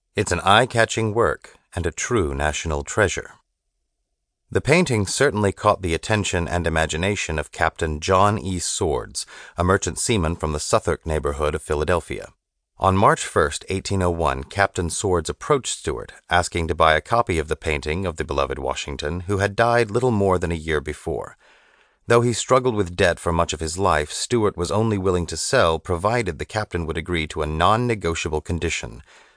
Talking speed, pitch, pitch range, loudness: 180 wpm, 90 Hz, 80-105 Hz, -21 LUFS